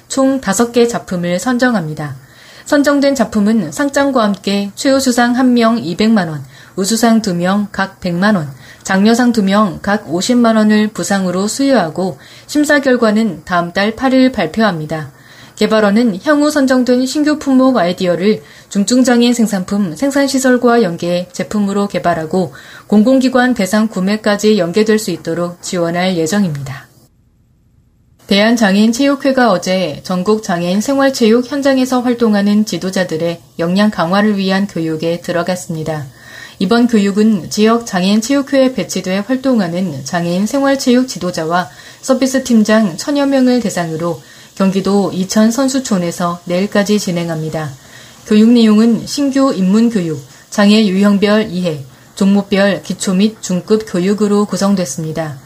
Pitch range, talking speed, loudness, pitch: 175-235 Hz, 305 characters per minute, -13 LUFS, 200 Hz